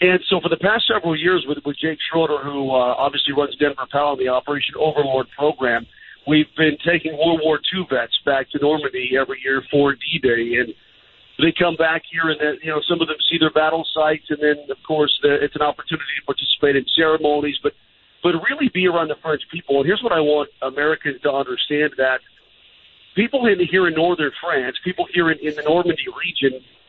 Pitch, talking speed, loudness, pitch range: 150 Hz, 210 wpm, -19 LUFS, 145-165 Hz